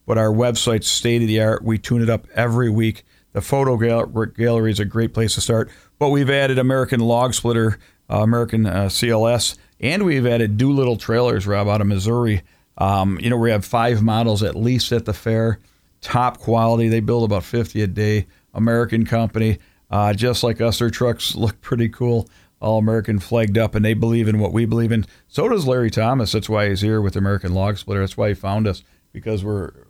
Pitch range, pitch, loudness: 105-120 Hz, 110 Hz, -19 LUFS